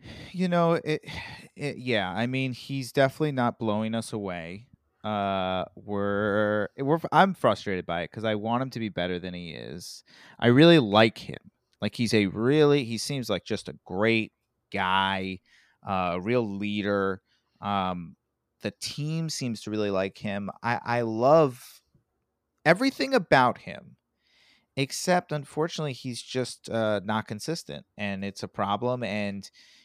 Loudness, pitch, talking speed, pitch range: -27 LUFS, 115 Hz, 150 wpm, 100-135 Hz